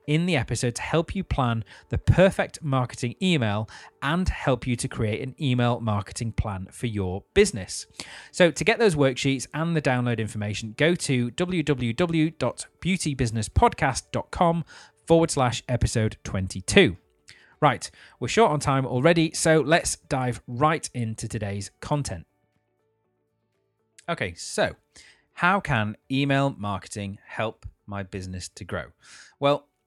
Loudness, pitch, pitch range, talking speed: -25 LUFS, 125 Hz, 110-155 Hz, 130 wpm